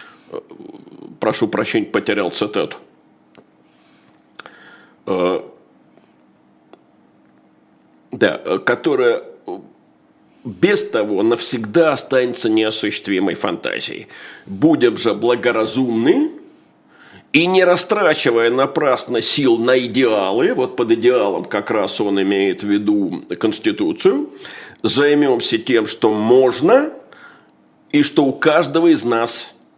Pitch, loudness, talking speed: 170 Hz, -16 LUFS, 85 wpm